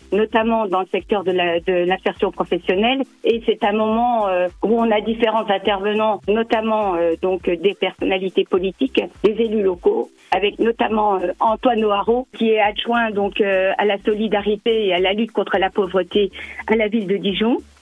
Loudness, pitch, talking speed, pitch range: -19 LUFS, 210 Hz, 180 wpm, 190-225 Hz